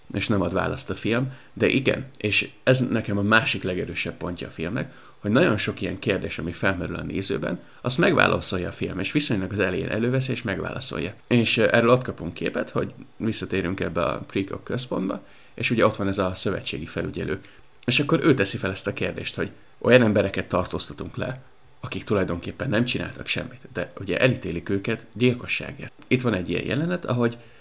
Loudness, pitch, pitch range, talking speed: -24 LUFS, 110 Hz, 95-125 Hz, 185 wpm